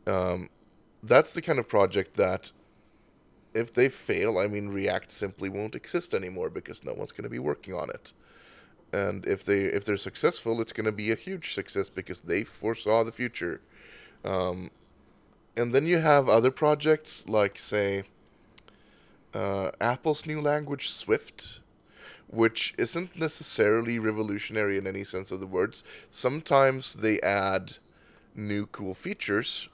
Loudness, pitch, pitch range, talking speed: -28 LUFS, 110 Hz, 100-140 Hz, 145 wpm